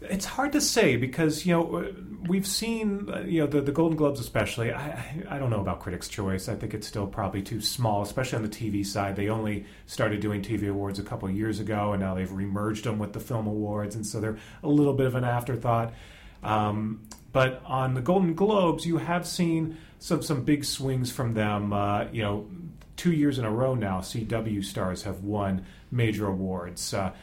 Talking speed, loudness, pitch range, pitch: 210 wpm, -28 LUFS, 105-145 Hz, 110 Hz